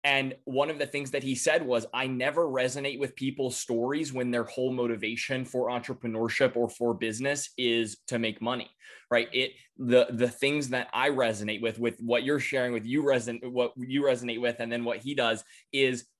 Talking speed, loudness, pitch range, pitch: 200 wpm, -29 LUFS, 120-135 Hz, 125 Hz